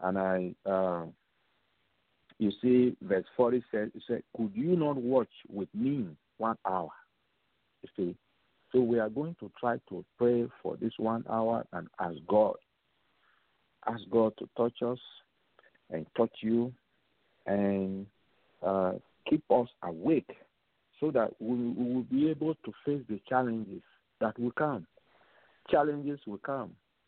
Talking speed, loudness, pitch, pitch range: 140 wpm, -32 LUFS, 115 Hz, 105-125 Hz